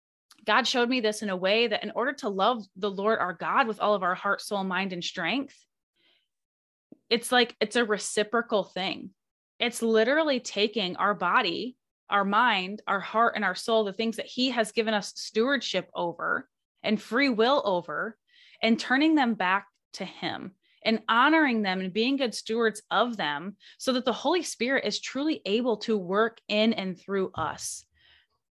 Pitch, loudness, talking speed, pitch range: 220 Hz, -27 LUFS, 180 wpm, 200-245 Hz